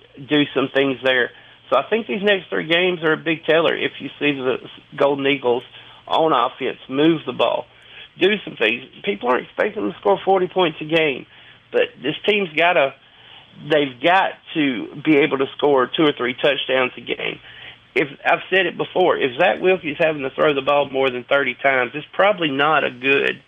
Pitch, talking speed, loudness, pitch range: 150 Hz, 195 wpm, -19 LUFS, 135-180 Hz